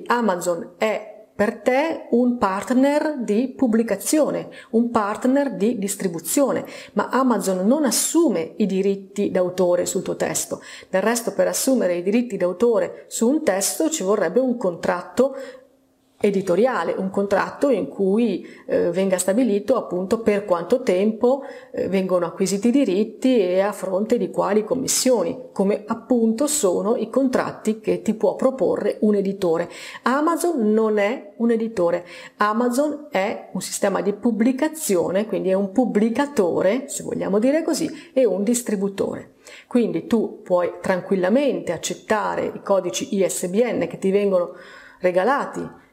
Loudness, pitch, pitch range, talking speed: -21 LUFS, 215 Hz, 195-260 Hz, 135 wpm